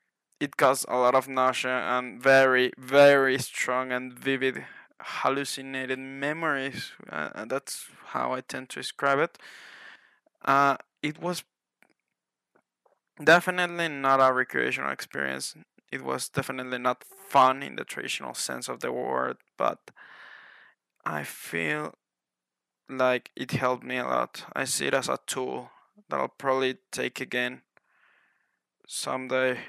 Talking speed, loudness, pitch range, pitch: 125 wpm, -27 LUFS, 125-135 Hz, 130 Hz